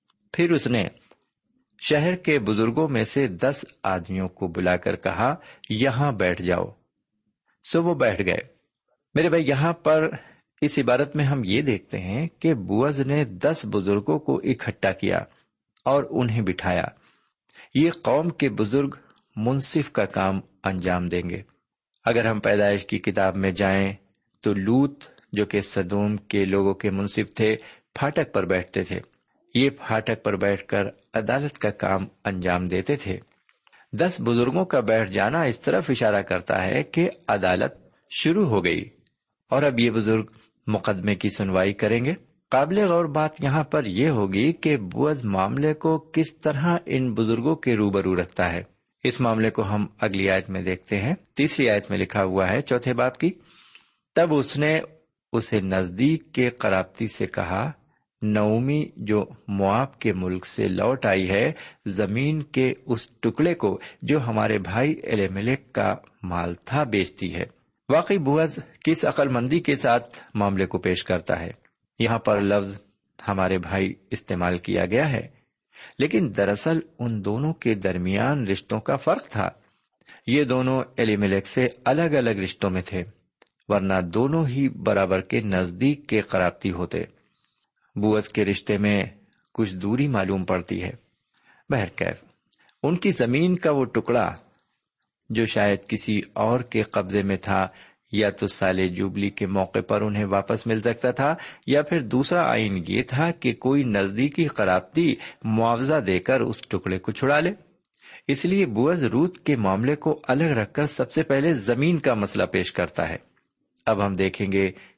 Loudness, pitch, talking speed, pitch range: -24 LUFS, 110 Hz, 160 wpm, 100-140 Hz